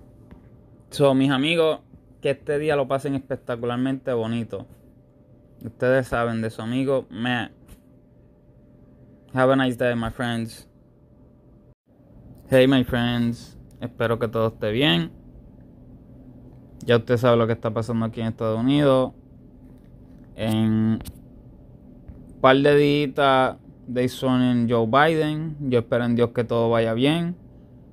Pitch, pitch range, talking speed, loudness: 125 Hz, 115-135 Hz, 125 wpm, -22 LUFS